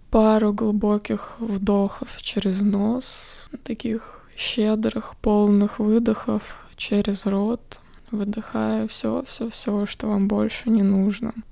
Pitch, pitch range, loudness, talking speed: 210 Hz, 205-225 Hz, -23 LUFS, 105 wpm